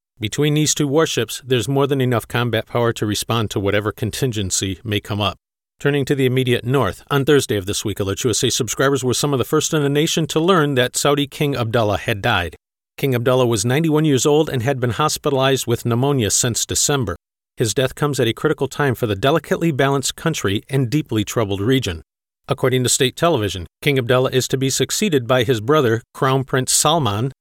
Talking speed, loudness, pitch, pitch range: 200 wpm, -18 LUFS, 130 Hz, 115-145 Hz